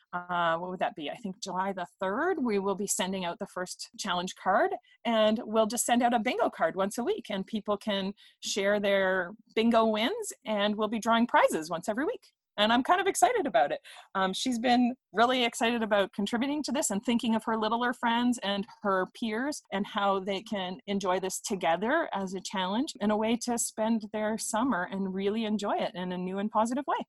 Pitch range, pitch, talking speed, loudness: 195-240 Hz, 215 Hz, 215 wpm, -29 LUFS